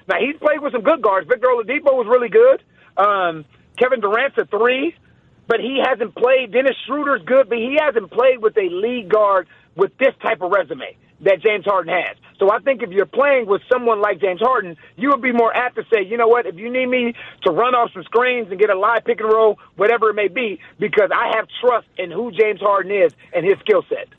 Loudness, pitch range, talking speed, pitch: -17 LUFS, 210-290 Hz, 235 wpm, 240 Hz